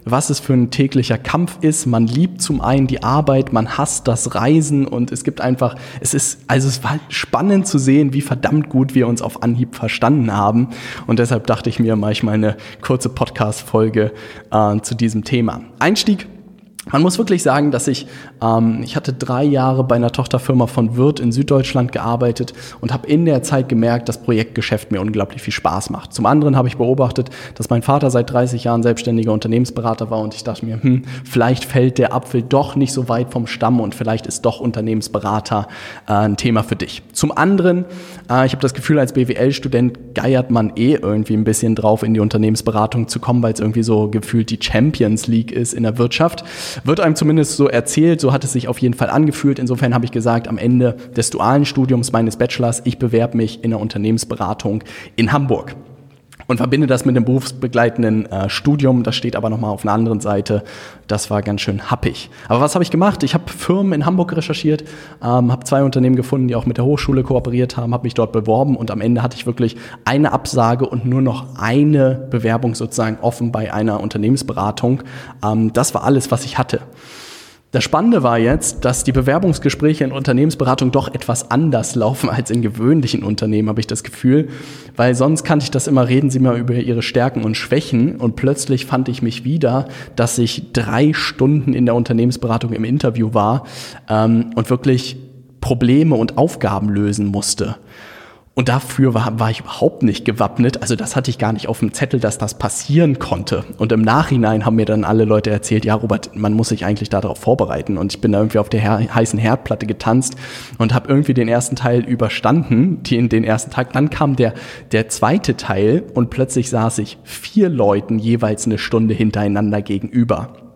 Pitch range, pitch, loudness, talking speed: 110-135 Hz, 120 Hz, -16 LUFS, 200 wpm